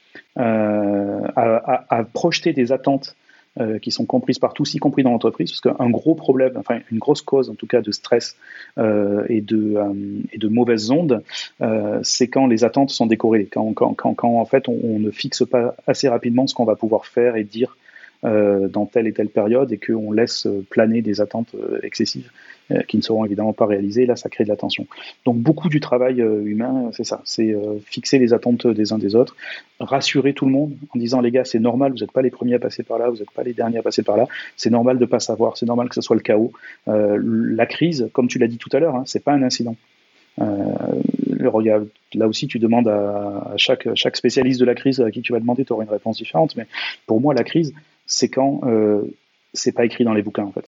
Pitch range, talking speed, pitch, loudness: 110-130 Hz, 240 wpm, 120 Hz, -19 LUFS